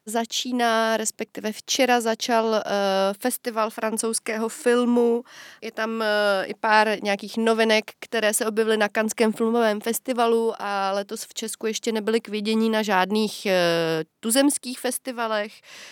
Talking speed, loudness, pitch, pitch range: 130 wpm, -23 LUFS, 220 Hz, 210-230 Hz